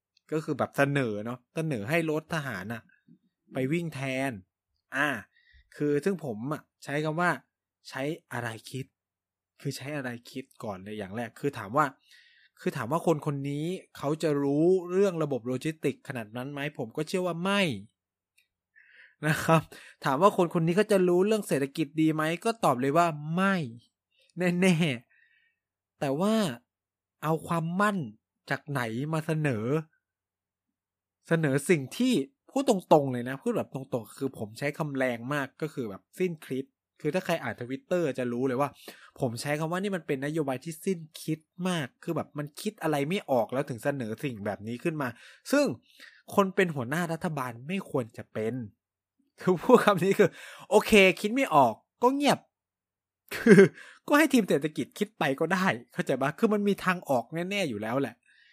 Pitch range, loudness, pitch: 130-180 Hz, -28 LUFS, 150 Hz